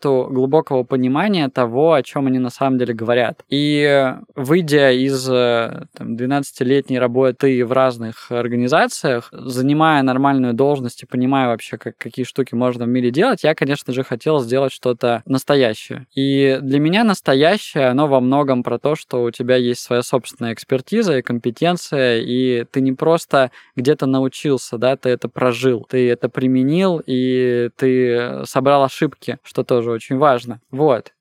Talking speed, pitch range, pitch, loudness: 150 wpm, 125-140 Hz, 130 Hz, -17 LUFS